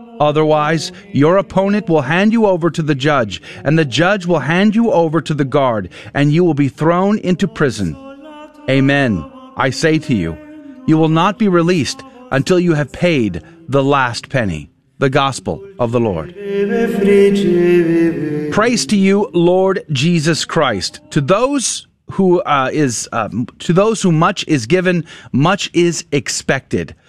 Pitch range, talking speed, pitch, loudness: 145-195 Hz, 155 wpm, 170 Hz, -15 LUFS